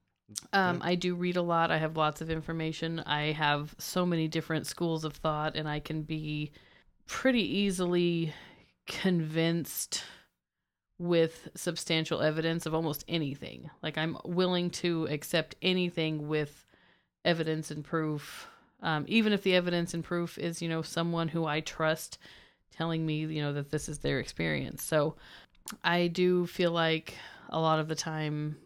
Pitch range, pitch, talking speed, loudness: 155-175 Hz, 160 Hz, 155 wpm, -31 LUFS